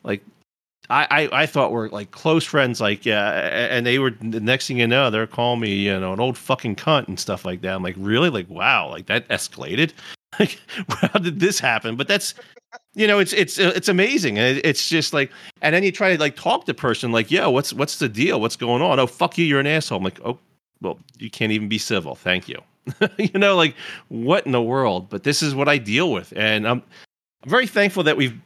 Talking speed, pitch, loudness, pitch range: 240 wpm, 130 Hz, -20 LUFS, 110-170 Hz